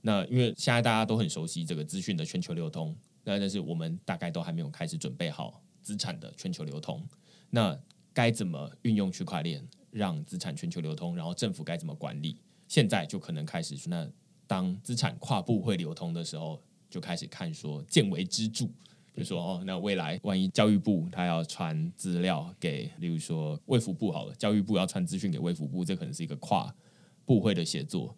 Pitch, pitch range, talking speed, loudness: 155 Hz, 105-170 Hz, 305 characters per minute, -32 LUFS